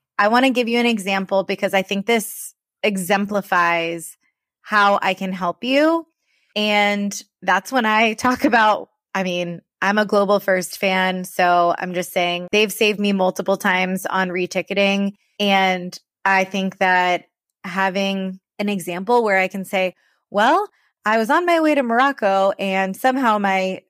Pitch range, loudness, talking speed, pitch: 185-215 Hz, -19 LUFS, 160 wpm, 195 Hz